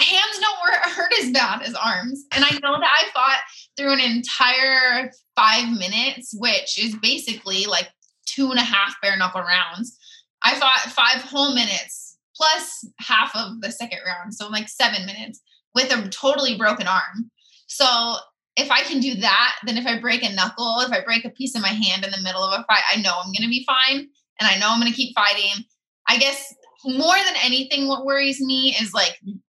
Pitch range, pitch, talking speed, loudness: 210-275 Hz, 240 Hz, 205 wpm, -19 LUFS